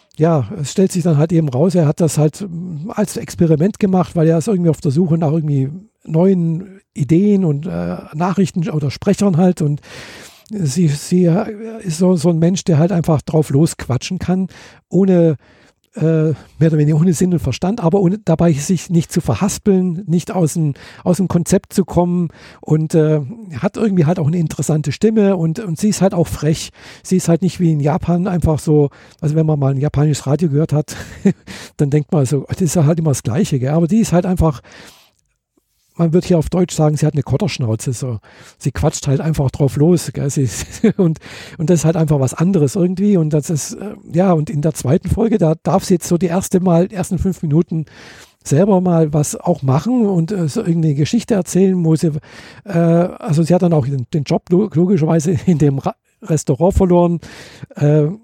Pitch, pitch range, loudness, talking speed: 165 Hz, 150-185 Hz, -16 LUFS, 200 wpm